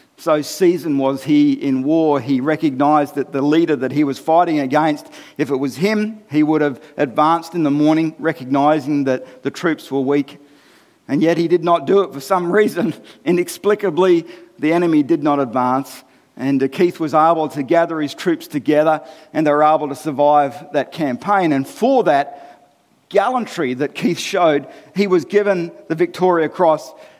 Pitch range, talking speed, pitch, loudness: 140-175 Hz, 175 wpm, 155 Hz, -17 LUFS